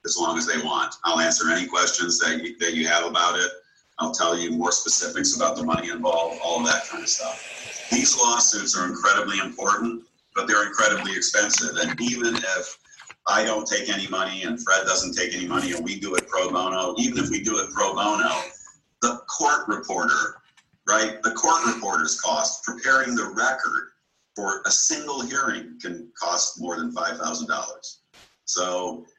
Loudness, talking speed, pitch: -22 LUFS, 185 wpm, 120 Hz